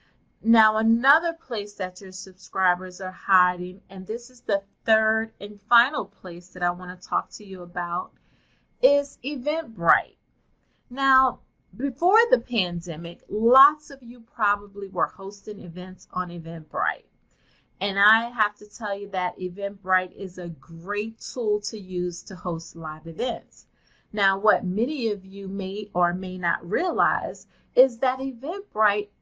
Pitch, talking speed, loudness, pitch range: 200 Hz, 145 wpm, -24 LUFS, 180-230 Hz